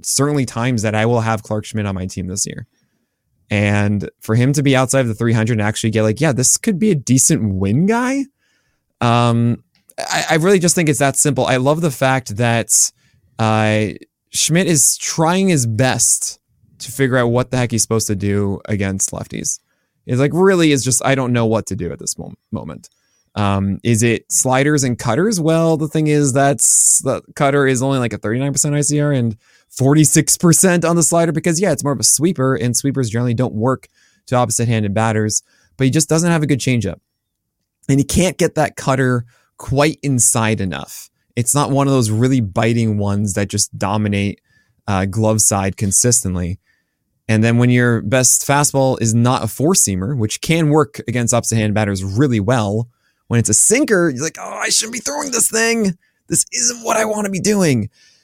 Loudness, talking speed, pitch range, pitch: -15 LUFS, 200 wpm, 110-150 Hz, 125 Hz